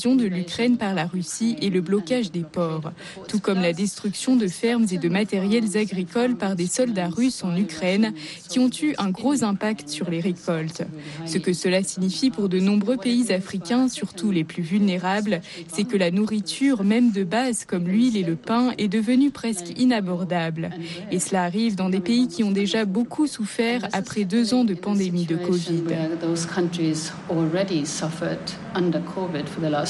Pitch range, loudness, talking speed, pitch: 175-225 Hz, -23 LUFS, 165 wpm, 195 Hz